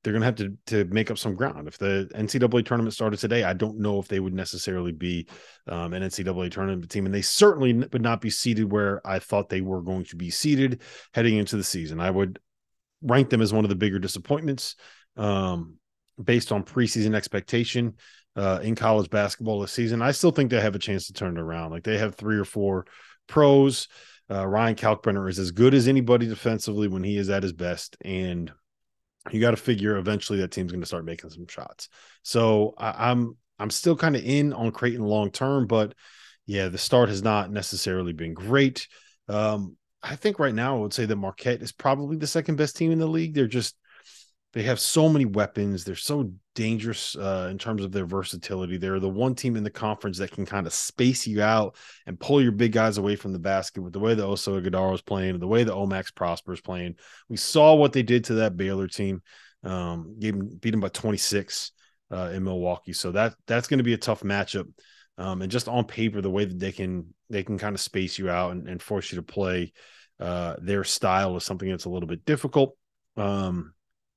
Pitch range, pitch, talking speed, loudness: 95-115 Hz, 105 Hz, 220 wpm, -25 LUFS